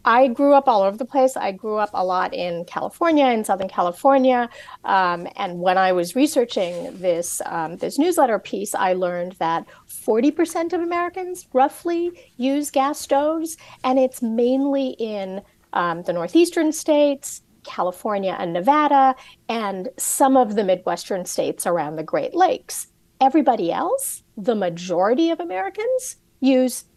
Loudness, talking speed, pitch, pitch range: -21 LUFS, 150 wpm, 255 Hz, 190-285 Hz